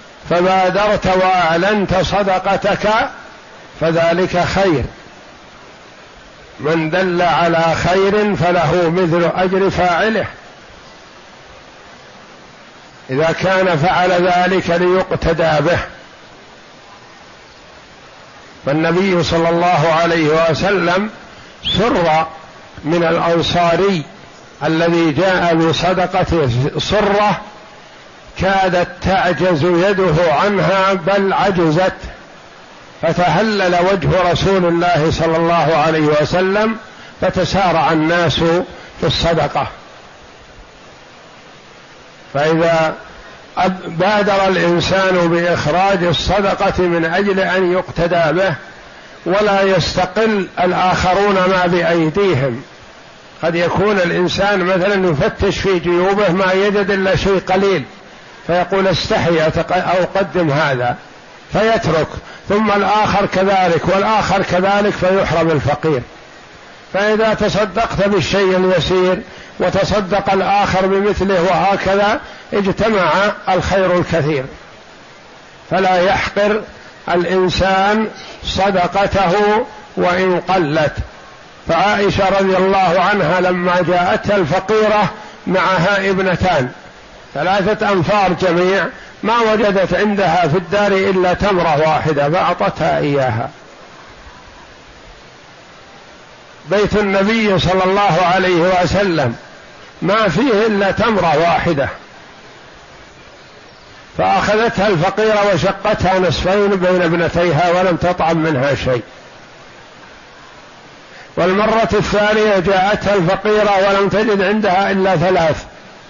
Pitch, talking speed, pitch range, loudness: 185 Hz, 80 wpm, 170-195 Hz, -14 LUFS